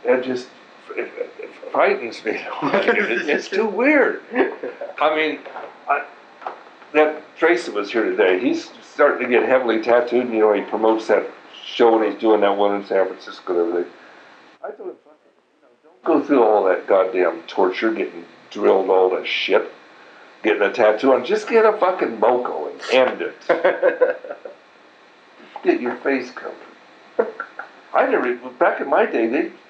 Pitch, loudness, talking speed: 150 Hz, -19 LUFS, 155 wpm